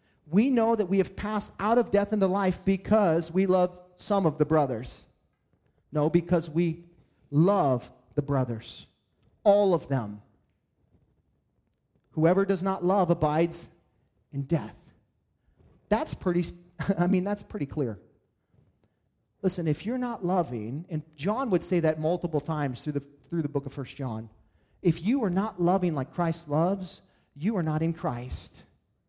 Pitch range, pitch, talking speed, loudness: 140-190 Hz, 170 Hz, 155 wpm, -28 LUFS